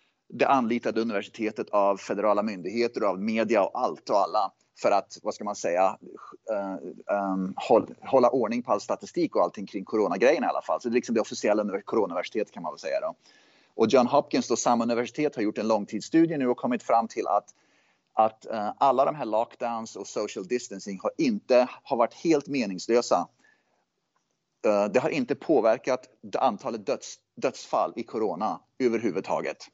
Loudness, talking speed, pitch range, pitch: -27 LUFS, 180 wpm, 105-125 Hz, 115 Hz